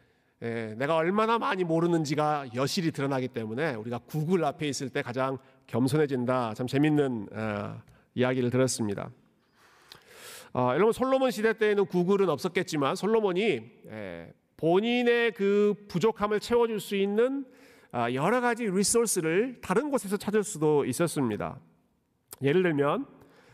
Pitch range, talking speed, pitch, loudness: 130-210 Hz, 305 characters per minute, 165 Hz, -28 LUFS